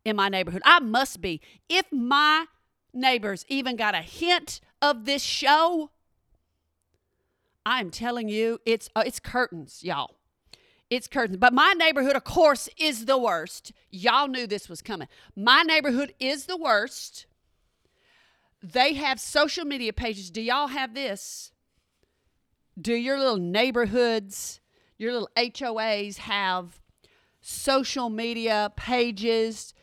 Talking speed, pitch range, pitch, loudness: 130 wpm, 220-280 Hz, 245 Hz, -24 LUFS